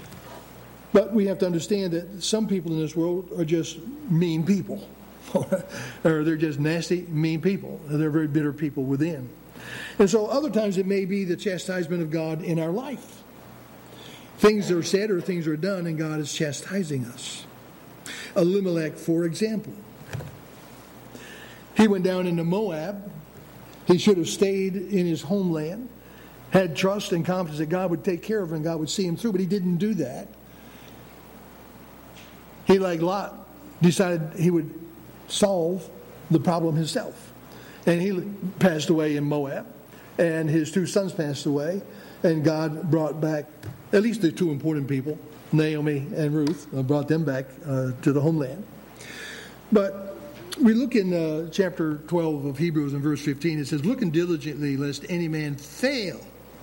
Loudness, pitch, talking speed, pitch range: -25 LUFS, 170 Hz, 160 wpm, 155-190 Hz